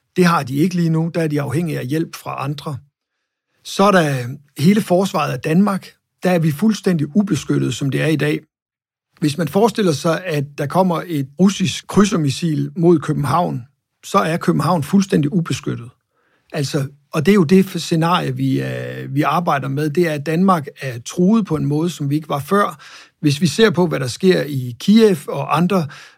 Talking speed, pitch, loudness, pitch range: 195 wpm, 160 Hz, -18 LUFS, 140-180 Hz